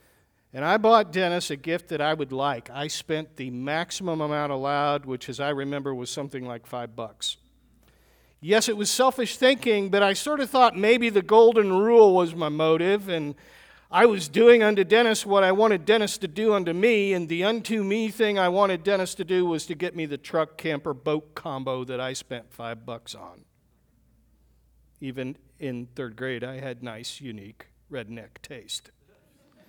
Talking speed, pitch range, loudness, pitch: 185 wpm, 130-200 Hz, -23 LUFS, 160 Hz